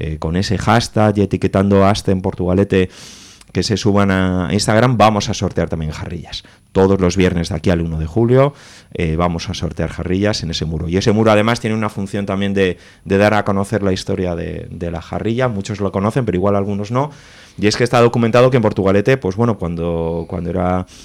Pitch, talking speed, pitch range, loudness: 95 Hz, 215 wpm, 90-105 Hz, -16 LUFS